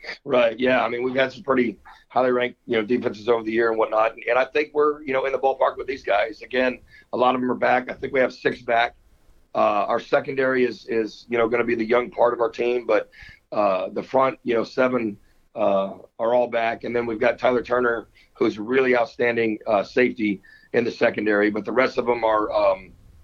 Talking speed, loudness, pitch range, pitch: 240 wpm, -22 LUFS, 110-125 Hz, 120 Hz